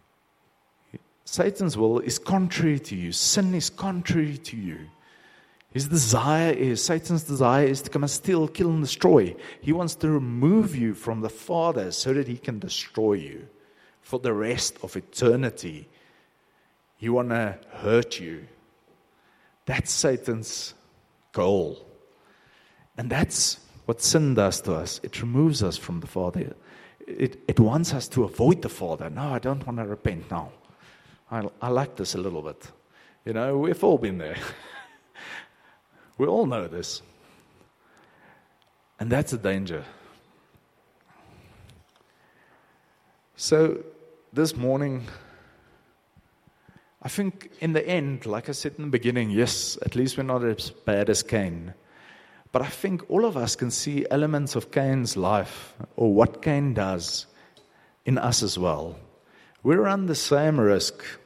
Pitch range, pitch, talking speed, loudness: 110-155 Hz, 125 Hz, 145 wpm, -25 LUFS